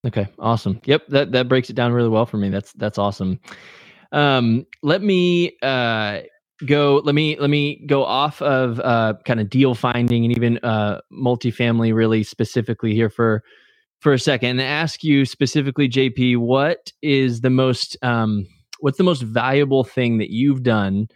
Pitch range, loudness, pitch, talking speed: 115-140 Hz, -19 LUFS, 125 Hz, 175 wpm